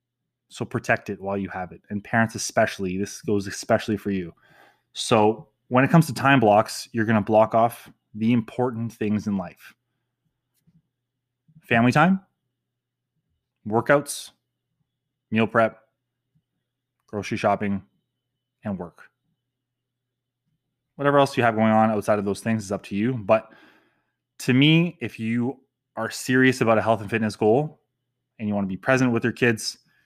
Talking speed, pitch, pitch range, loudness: 155 wpm, 120 Hz, 110-130 Hz, -22 LUFS